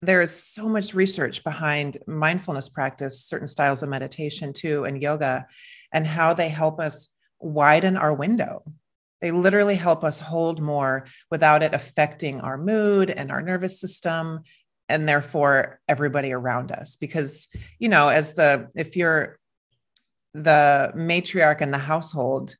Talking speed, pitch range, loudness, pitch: 145 wpm, 145-170 Hz, -22 LUFS, 155 Hz